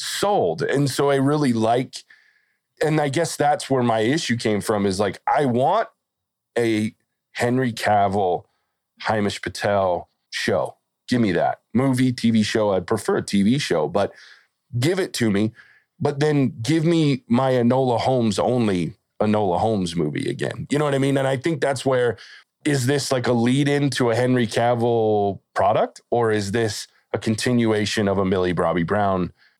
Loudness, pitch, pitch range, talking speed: -21 LUFS, 120 Hz, 110-140 Hz, 170 wpm